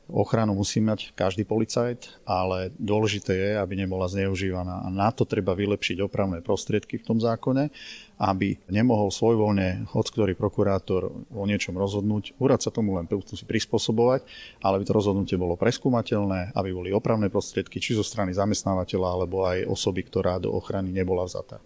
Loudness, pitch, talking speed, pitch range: -26 LUFS, 100 Hz, 160 wpm, 95-110 Hz